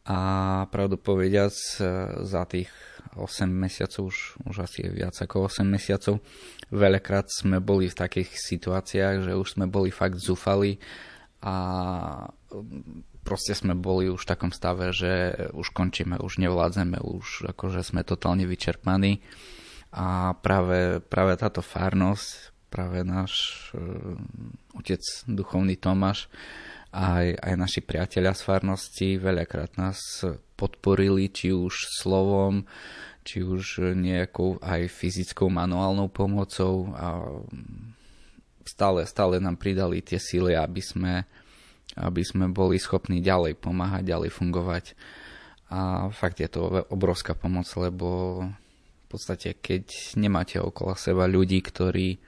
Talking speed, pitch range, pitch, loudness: 125 wpm, 90-95 Hz, 95 Hz, -27 LUFS